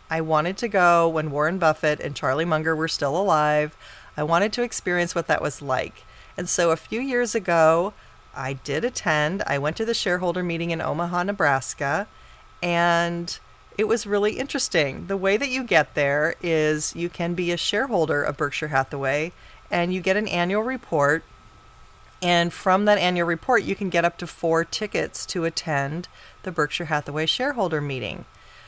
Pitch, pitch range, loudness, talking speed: 170 Hz, 155-190 Hz, -23 LUFS, 175 wpm